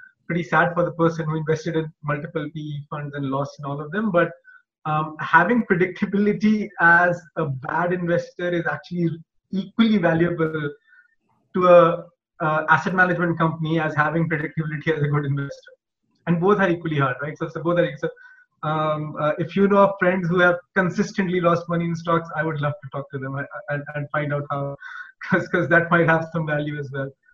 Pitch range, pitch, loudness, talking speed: 150-180 Hz, 165 Hz, -22 LUFS, 185 wpm